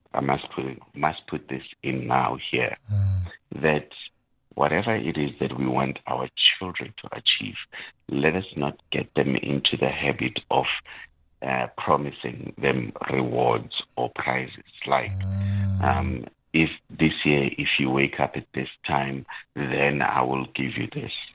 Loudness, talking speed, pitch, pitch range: -25 LUFS, 150 wpm, 70 Hz, 65-80 Hz